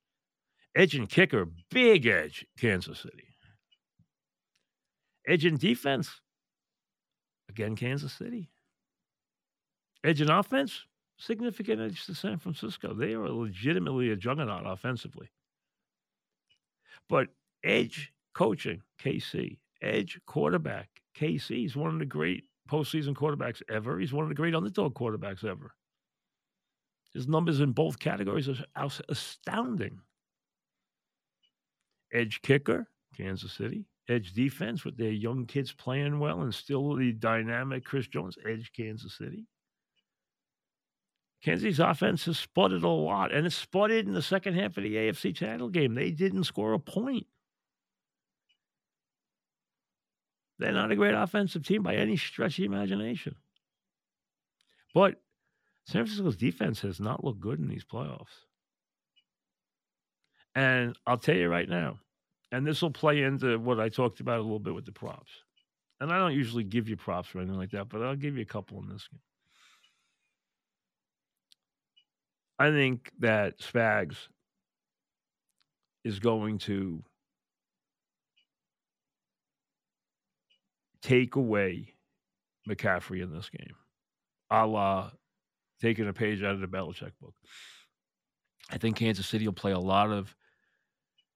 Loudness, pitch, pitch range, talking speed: -30 LUFS, 125 Hz, 105-155 Hz, 130 wpm